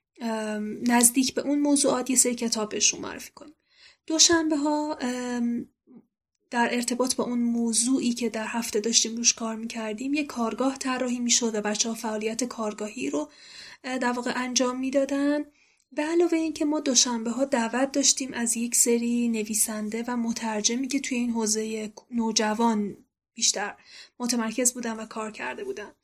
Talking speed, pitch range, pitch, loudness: 150 wpm, 225-270 Hz, 240 Hz, -25 LUFS